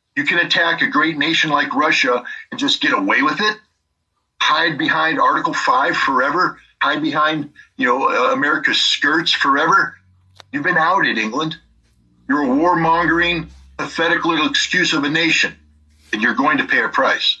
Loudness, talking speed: -16 LUFS, 160 wpm